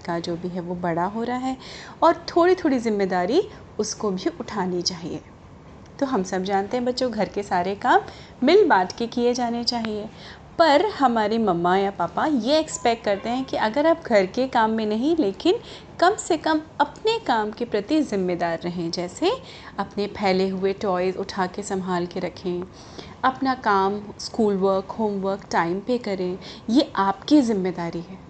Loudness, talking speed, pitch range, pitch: -23 LUFS, 175 wpm, 190-260 Hz, 210 Hz